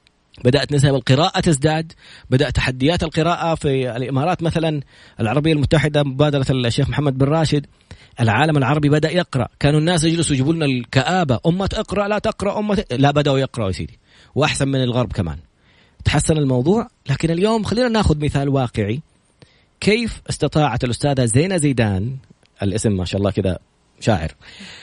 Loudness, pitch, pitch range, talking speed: -18 LUFS, 145 Hz, 125-165 Hz, 145 wpm